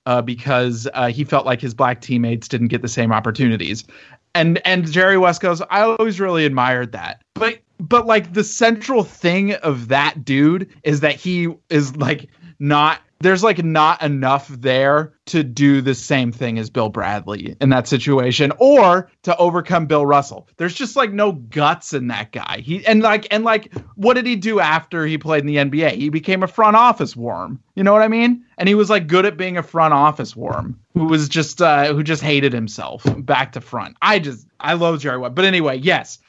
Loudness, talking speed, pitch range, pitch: -17 LUFS, 205 wpm, 130-185 Hz, 150 Hz